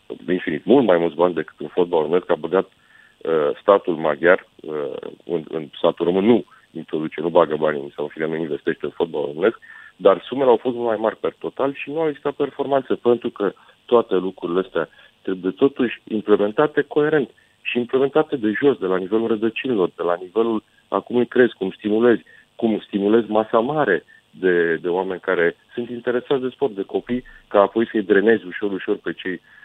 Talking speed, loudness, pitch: 190 wpm, -21 LUFS, 125 Hz